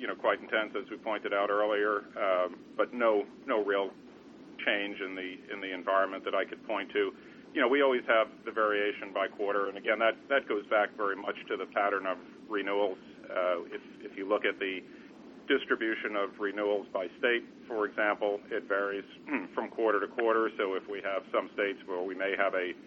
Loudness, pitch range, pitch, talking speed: -31 LUFS, 100-110 Hz, 100 Hz, 205 wpm